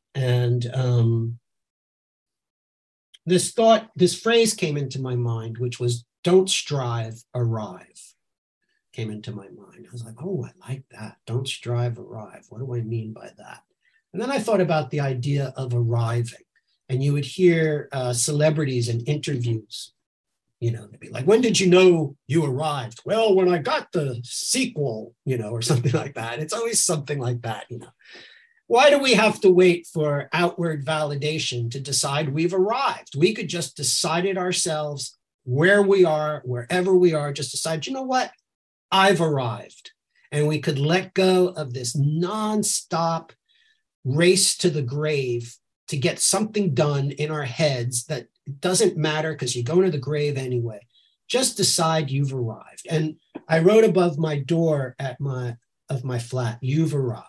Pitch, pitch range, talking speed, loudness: 150 Hz, 125-180 Hz, 170 wpm, -22 LUFS